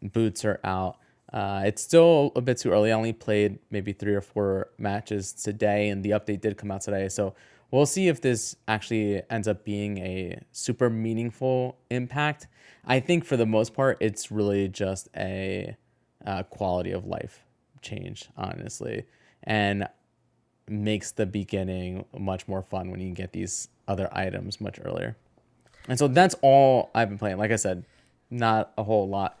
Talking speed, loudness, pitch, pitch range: 175 wpm, -26 LUFS, 105 Hz, 100-120 Hz